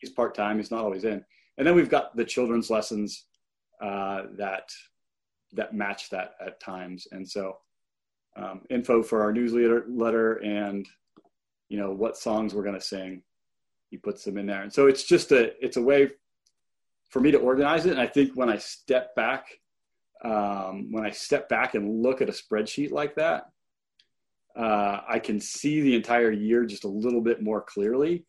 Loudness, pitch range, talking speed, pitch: -26 LUFS, 100-120 Hz, 185 wpm, 110 Hz